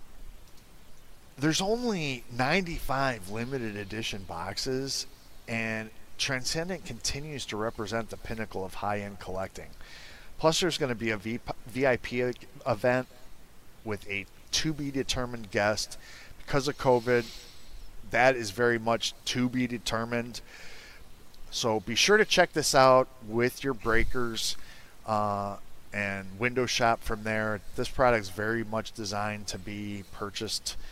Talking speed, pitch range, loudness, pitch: 120 wpm, 105-130 Hz, -29 LUFS, 115 Hz